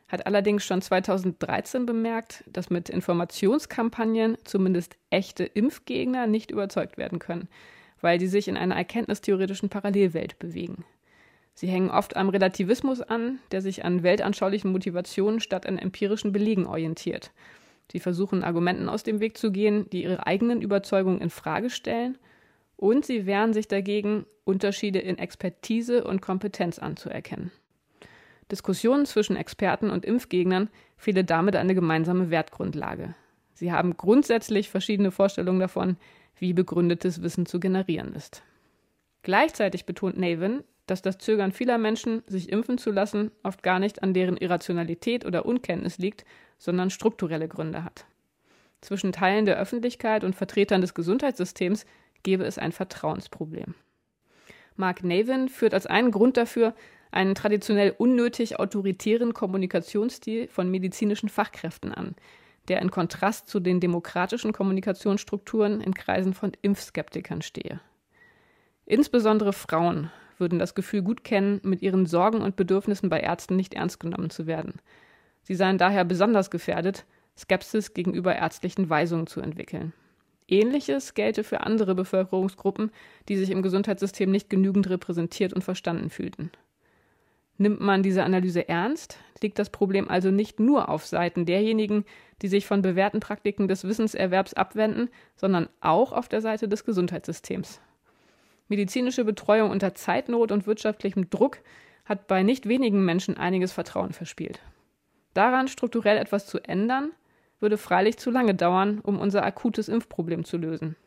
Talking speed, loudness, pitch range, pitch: 140 wpm, -26 LUFS, 185-215 Hz, 195 Hz